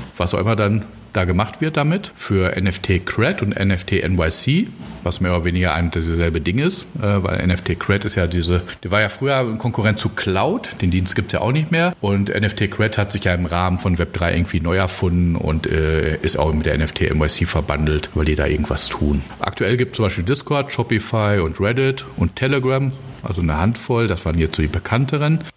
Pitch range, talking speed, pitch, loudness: 85-115 Hz, 215 wpm, 95 Hz, -19 LUFS